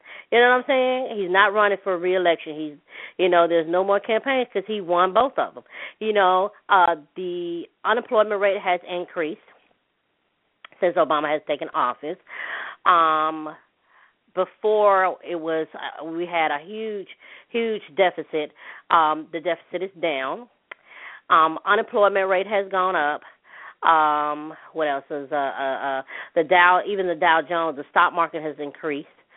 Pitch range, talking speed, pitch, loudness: 155-200 Hz, 155 wpm, 175 Hz, -22 LUFS